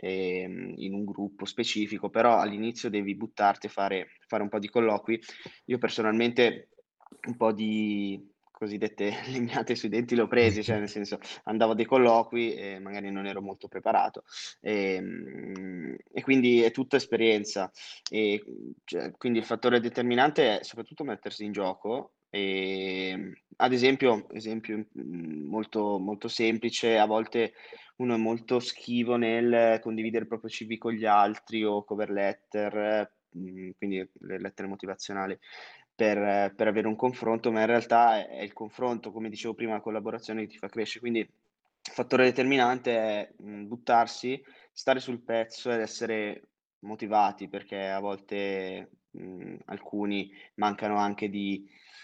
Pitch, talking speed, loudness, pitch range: 110 Hz, 140 wpm, -29 LUFS, 100-115 Hz